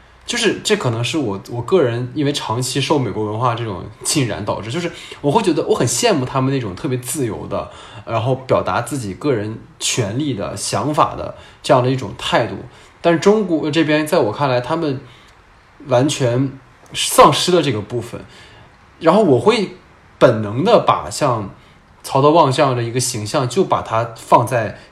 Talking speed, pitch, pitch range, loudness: 265 characters per minute, 130 Hz, 115-150 Hz, -17 LUFS